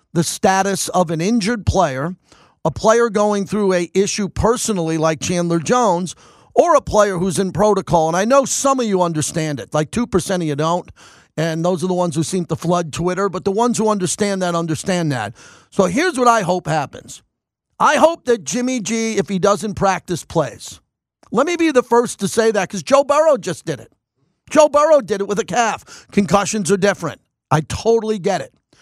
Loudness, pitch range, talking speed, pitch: -17 LUFS, 170-225 Hz, 205 wpm, 195 Hz